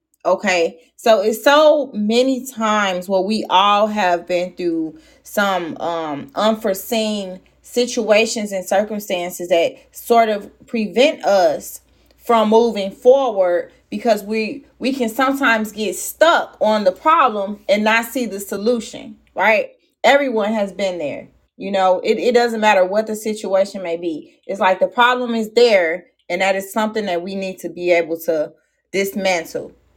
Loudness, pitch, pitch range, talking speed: -17 LUFS, 215 Hz, 190-245 Hz, 150 wpm